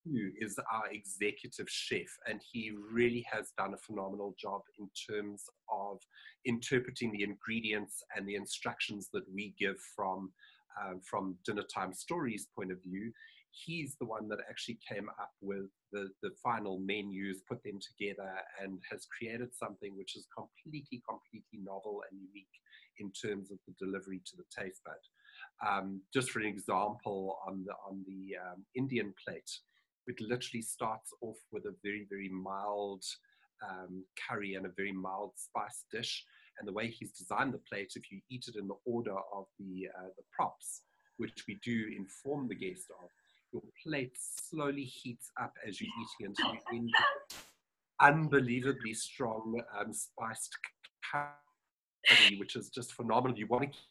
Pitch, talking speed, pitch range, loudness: 105 Hz, 165 wpm, 95-120 Hz, -37 LUFS